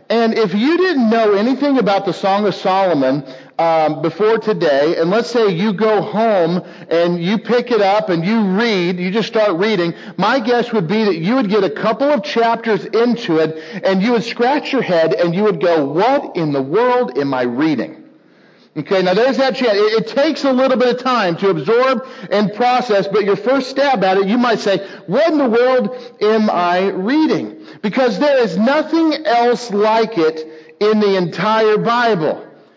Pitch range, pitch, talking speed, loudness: 190-245 Hz, 215 Hz, 195 wpm, -15 LUFS